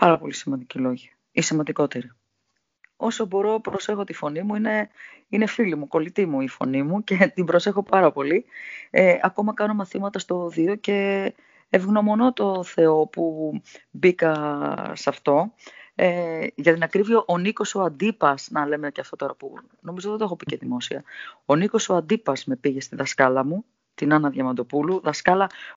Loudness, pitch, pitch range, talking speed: -23 LUFS, 180 Hz, 155-210 Hz, 170 wpm